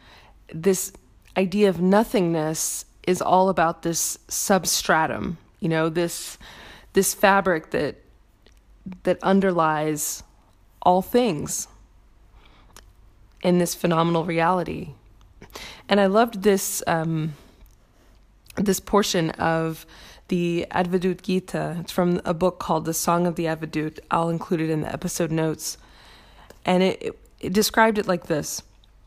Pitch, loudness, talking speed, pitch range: 170 Hz, -23 LUFS, 120 wpm, 155-185 Hz